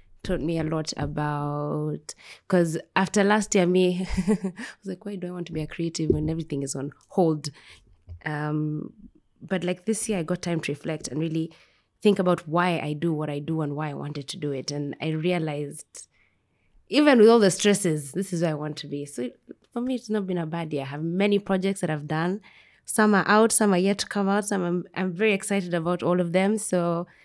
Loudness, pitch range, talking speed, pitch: -25 LUFS, 150-195 Hz, 225 wpm, 175 Hz